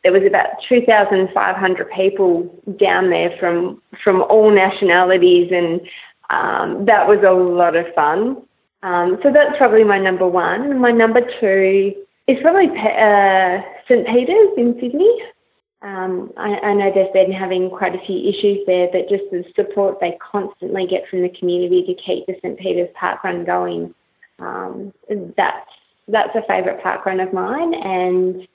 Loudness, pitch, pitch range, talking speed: -16 LUFS, 190 Hz, 185-210 Hz, 165 wpm